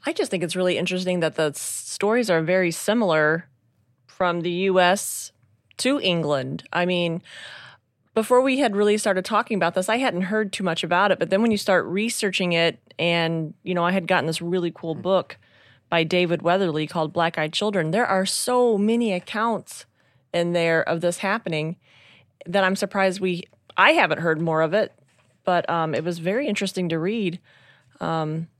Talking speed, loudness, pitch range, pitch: 185 wpm, -22 LUFS, 160-195 Hz, 175 Hz